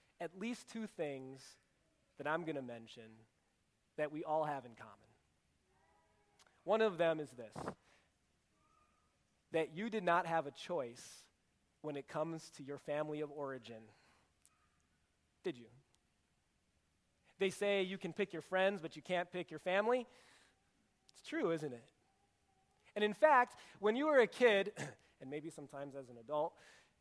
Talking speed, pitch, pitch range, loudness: 150 wpm, 150 Hz, 115-190 Hz, -39 LUFS